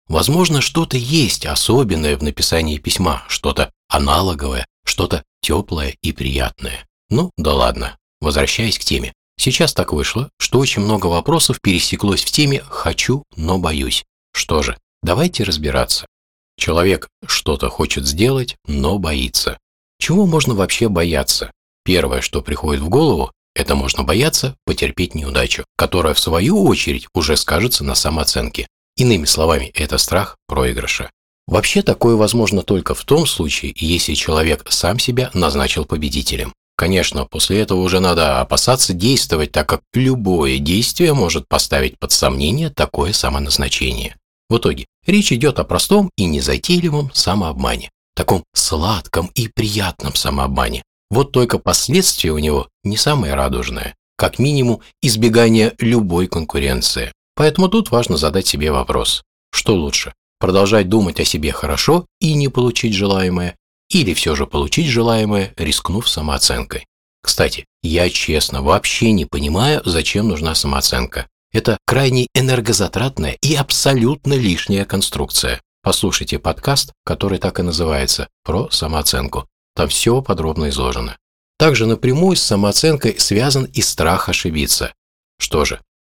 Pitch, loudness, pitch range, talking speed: 95 Hz, -16 LUFS, 75-125 Hz, 130 wpm